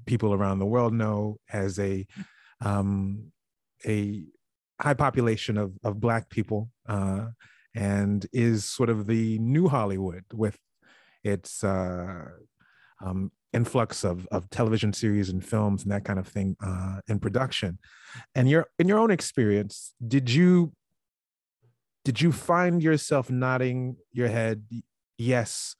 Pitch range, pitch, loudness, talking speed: 100-125 Hz, 110 Hz, -27 LUFS, 135 wpm